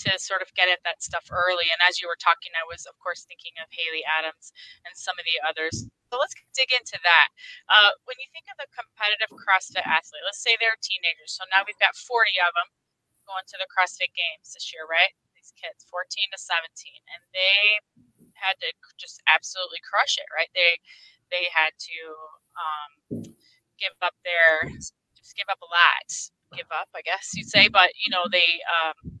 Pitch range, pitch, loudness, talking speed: 170-230 Hz, 185 Hz, -22 LUFS, 200 wpm